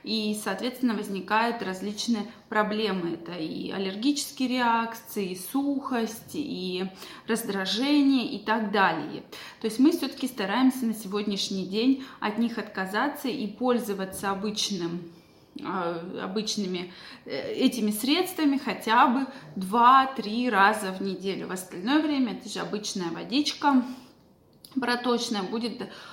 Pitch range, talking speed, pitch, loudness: 195-255 Hz, 110 wpm, 220 Hz, -27 LUFS